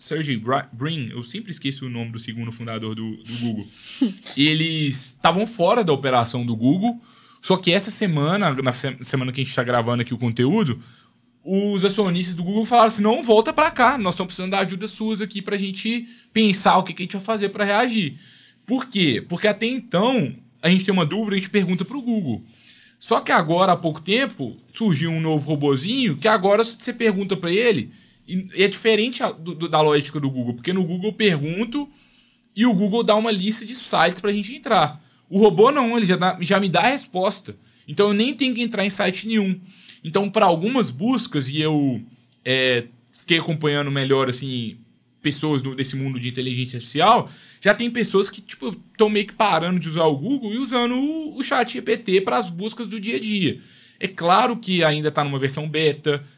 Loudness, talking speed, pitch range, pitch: -21 LUFS, 205 wpm, 145-220 Hz, 185 Hz